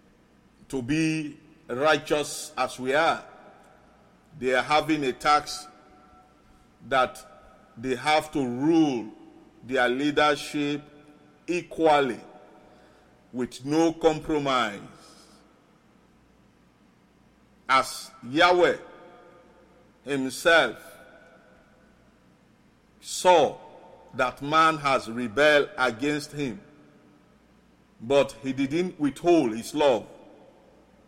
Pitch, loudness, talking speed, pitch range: 150 Hz, -25 LUFS, 75 wpm, 135-160 Hz